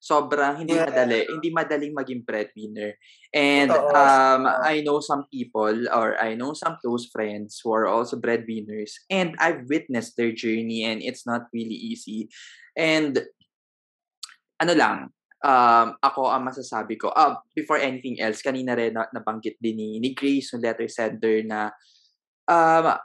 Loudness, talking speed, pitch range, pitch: -23 LUFS, 155 wpm, 110-150 Hz, 125 Hz